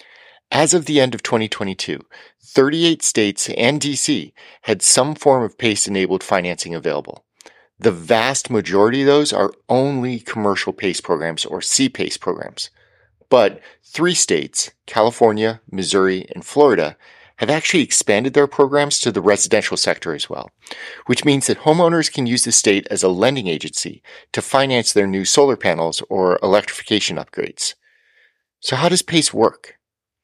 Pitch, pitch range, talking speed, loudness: 130 Hz, 105-150 Hz, 150 wpm, -17 LUFS